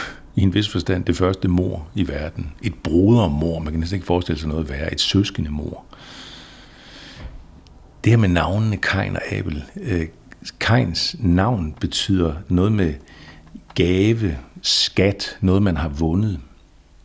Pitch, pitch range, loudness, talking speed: 90 Hz, 80-95 Hz, -20 LUFS, 145 wpm